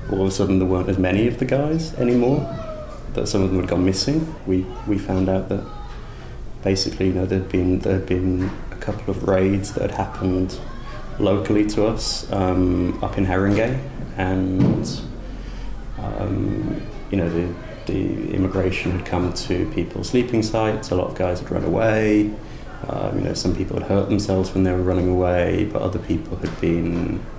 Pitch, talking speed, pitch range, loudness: 95 Hz, 180 wpm, 90-110 Hz, -22 LUFS